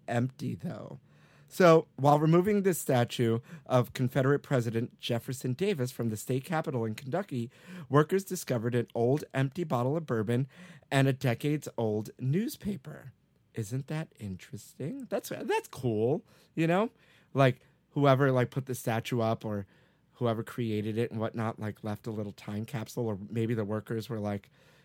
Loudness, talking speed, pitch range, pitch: -31 LUFS, 150 wpm, 115-155 Hz, 130 Hz